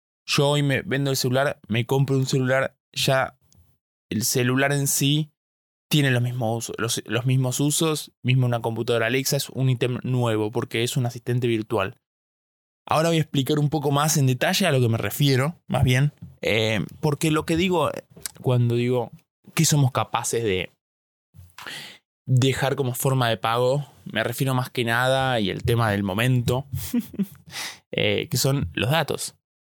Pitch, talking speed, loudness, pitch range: 130 Hz, 170 wpm, -23 LUFS, 120-145 Hz